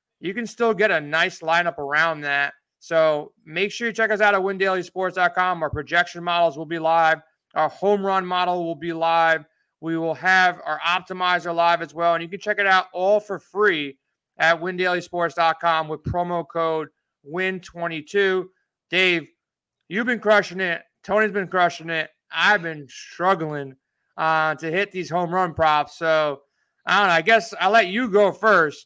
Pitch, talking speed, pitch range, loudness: 175 Hz, 175 wpm, 160-190 Hz, -21 LUFS